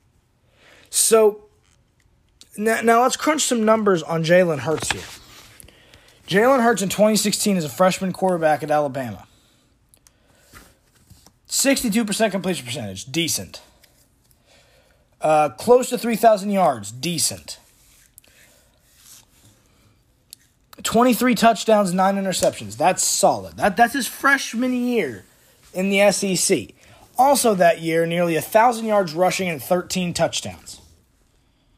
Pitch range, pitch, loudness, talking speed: 145-225 Hz, 185 Hz, -19 LUFS, 105 wpm